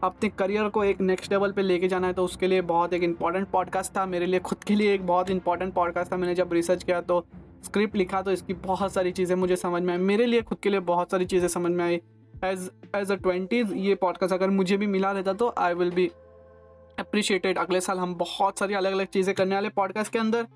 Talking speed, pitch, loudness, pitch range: 245 wpm, 185 Hz, -26 LUFS, 180-195 Hz